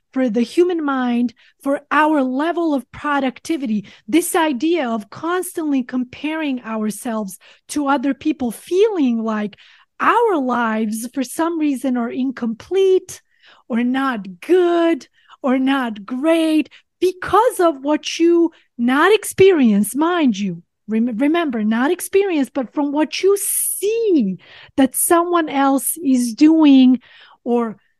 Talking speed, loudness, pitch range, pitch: 120 wpm, -18 LUFS, 245-335 Hz, 280 Hz